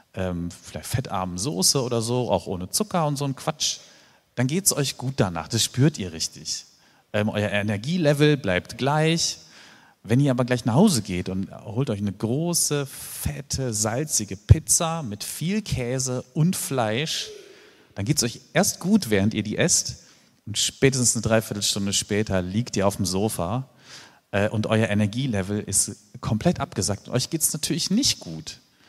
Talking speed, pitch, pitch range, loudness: 170 wpm, 120 Hz, 105-150 Hz, -23 LUFS